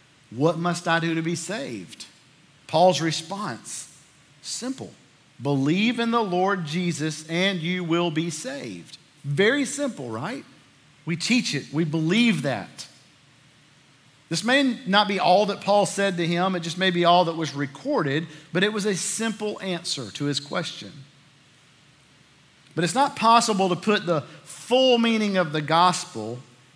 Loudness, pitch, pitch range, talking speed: -23 LUFS, 170 Hz, 145-200 Hz, 155 wpm